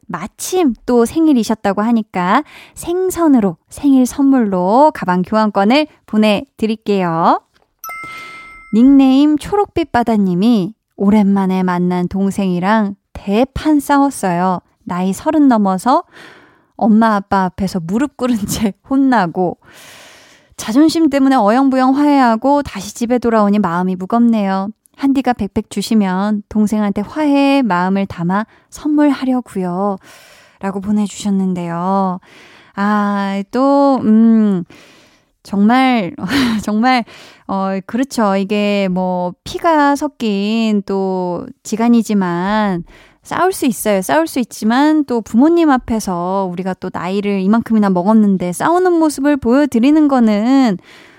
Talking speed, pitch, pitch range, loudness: 255 characters per minute, 220 Hz, 195-270 Hz, -14 LUFS